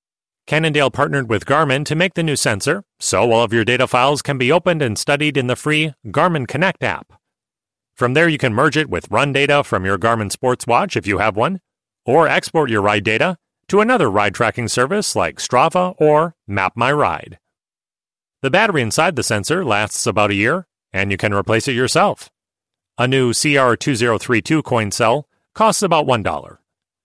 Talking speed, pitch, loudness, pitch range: 185 wpm, 130 Hz, -16 LUFS, 110-155 Hz